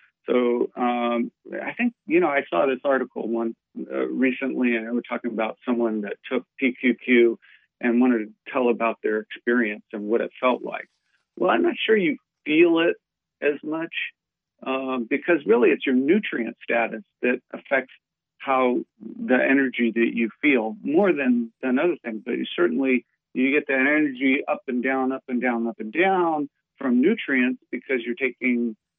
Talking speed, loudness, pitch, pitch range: 175 wpm, -23 LUFS, 125 Hz, 115-145 Hz